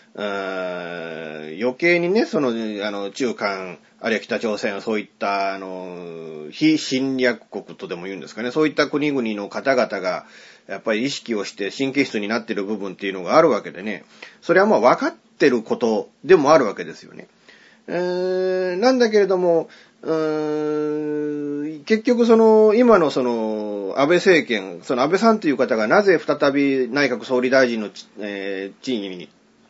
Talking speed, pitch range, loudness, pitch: 305 characters per minute, 100-155 Hz, -20 LUFS, 130 Hz